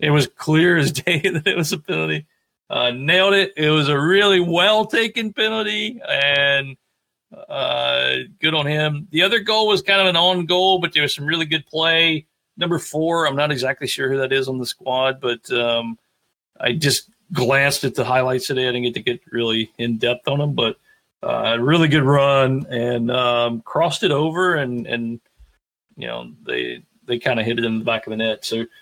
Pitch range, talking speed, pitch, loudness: 120-170 Hz, 210 wpm, 140 Hz, -18 LUFS